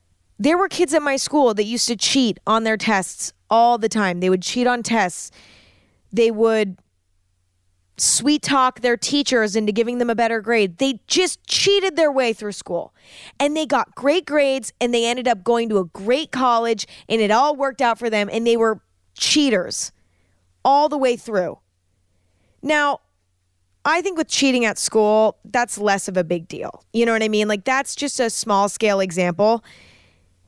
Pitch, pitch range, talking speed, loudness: 225 Hz, 180-255 Hz, 185 wpm, -19 LUFS